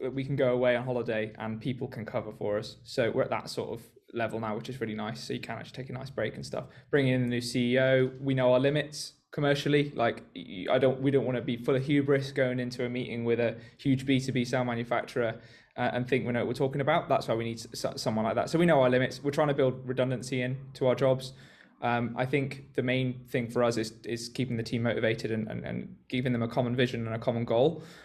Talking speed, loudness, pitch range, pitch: 265 wpm, -30 LUFS, 120-135 Hz, 125 Hz